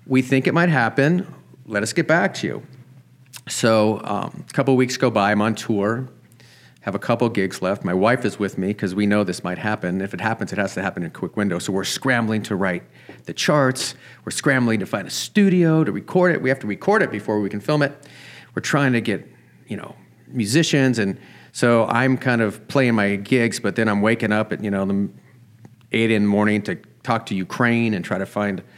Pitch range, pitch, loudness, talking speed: 105-130 Hz, 115 Hz, -20 LUFS, 230 wpm